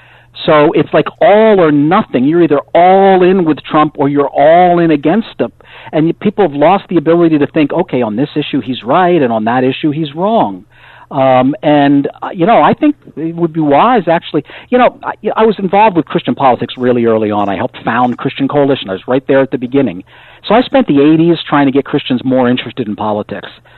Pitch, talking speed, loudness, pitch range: 150 Hz, 220 wpm, -11 LUFS, 130-170 Hz